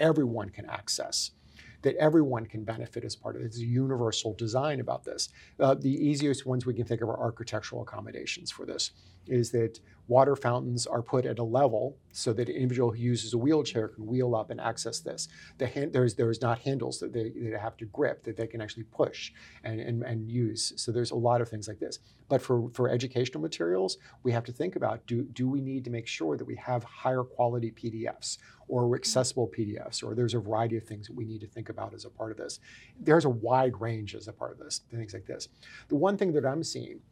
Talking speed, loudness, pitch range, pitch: 230 wpm, -31 LUFS, 115-130 Hz, 120 Hz